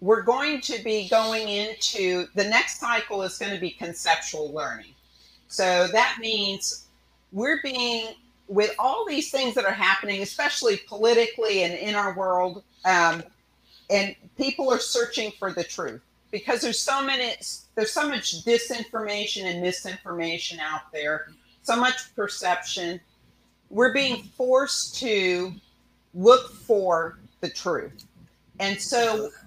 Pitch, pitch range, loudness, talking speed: 205 Hz, 180-240 Hz, -24 LUFS, 135 wpm